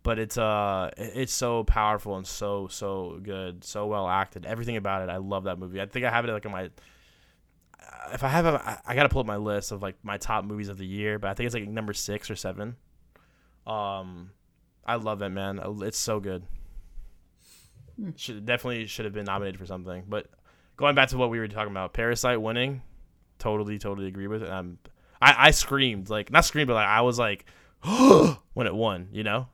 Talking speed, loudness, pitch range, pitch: 210 wpm, -26 LUFS, 95-115 Hz, 105 Hz